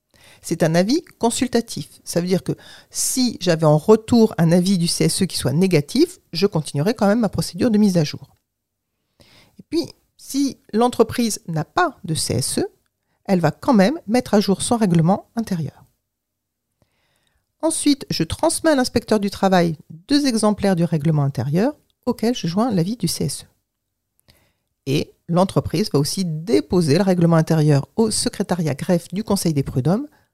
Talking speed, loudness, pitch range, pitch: 160 wpm, -19 LUFS, 150-225 Hz, 180 Hz